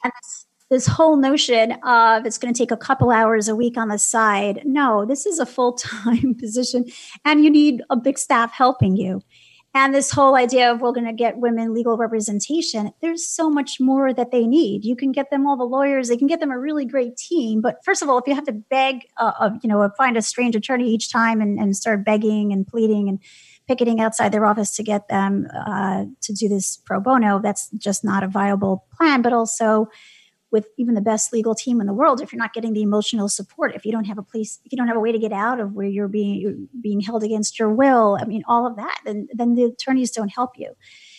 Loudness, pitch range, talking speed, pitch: -19 LUFS, 215-260 Hz, 235 wpm, 230 Hz